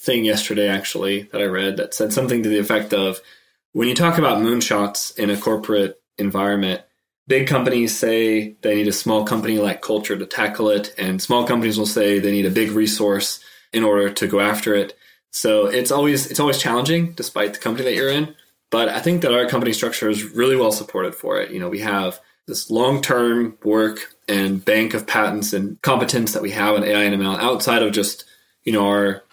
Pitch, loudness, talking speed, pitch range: 105 Hz, -19 LUFS, 210 wpm, 100-120 Hz